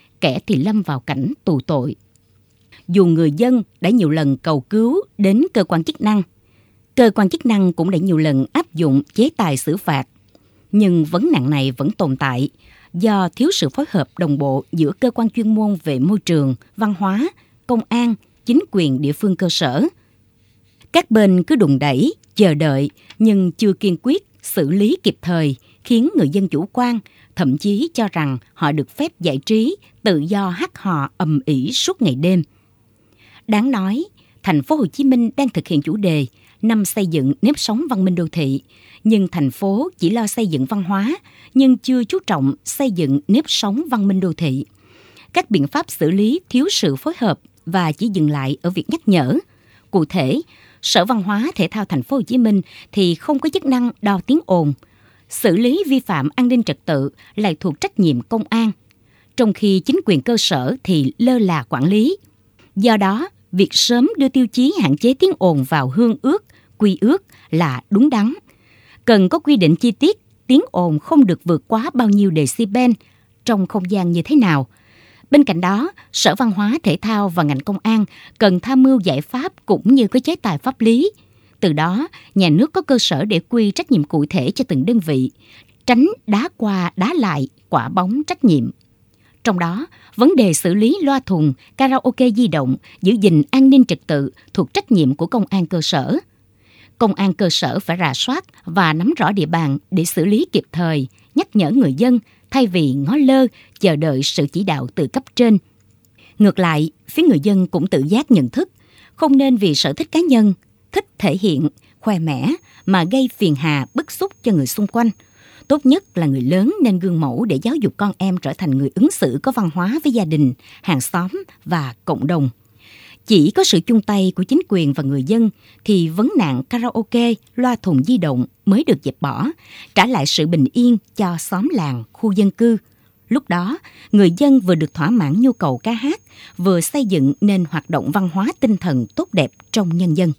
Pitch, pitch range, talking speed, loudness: 195 Hz, 155-245 Hz, 205 wpm, -17 LUFS